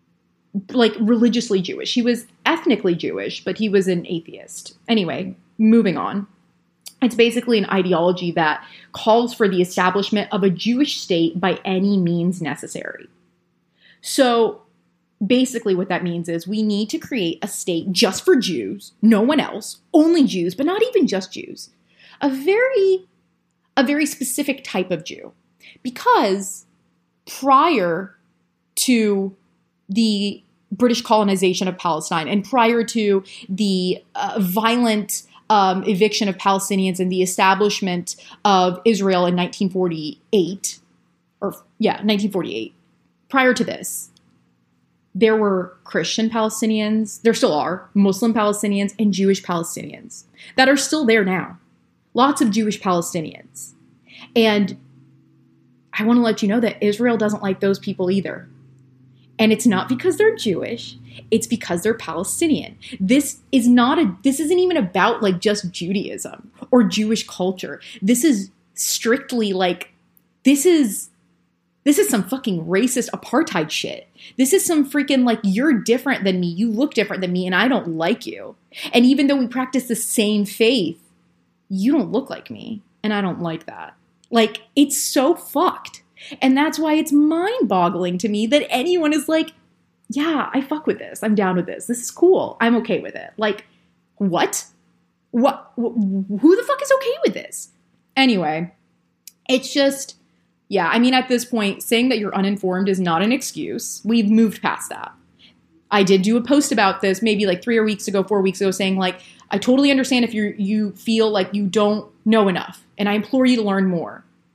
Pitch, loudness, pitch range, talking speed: 215 Hz, -19 LUFS, 190-245 Hz, 160 wpm